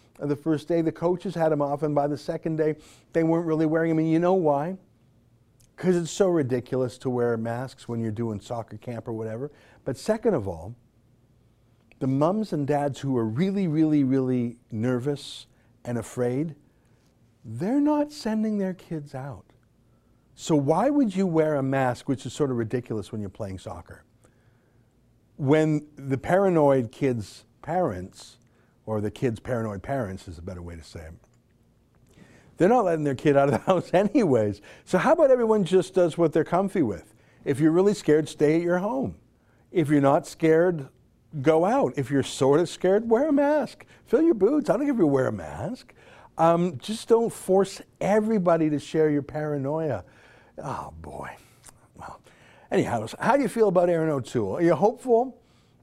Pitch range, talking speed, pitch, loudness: 120-175 Hz, 180 wpm, 145 Hz, -25 LUFS